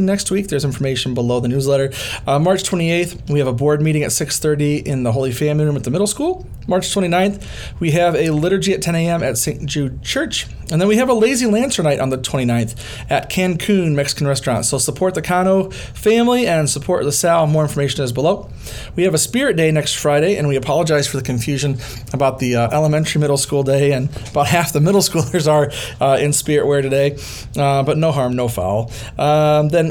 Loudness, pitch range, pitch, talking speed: -17 LUFS, 135-170 Hz, 145 Hz, 210 wpm